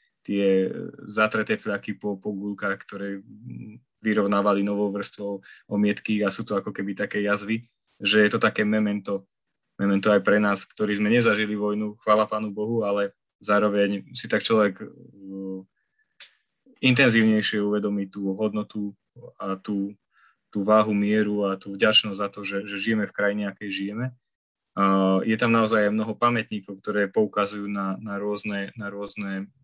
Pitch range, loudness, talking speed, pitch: 100-110 Hz, -24 LUFS, 145 wpm, 105 Hz